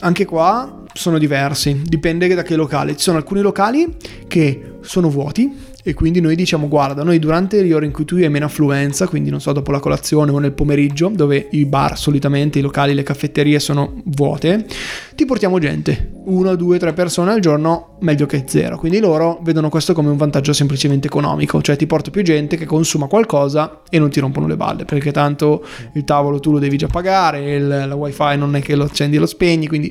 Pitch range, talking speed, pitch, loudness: 145-170 Hz, 210 wpm, 150 Hz, -16 LUFS